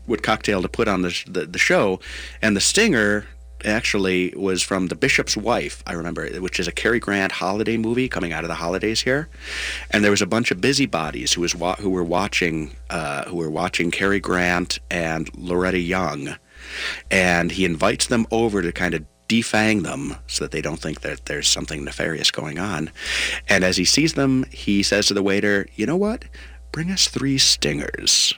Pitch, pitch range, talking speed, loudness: 95 Hz, 85-110 Hz, 200 wpm, -21 LUFS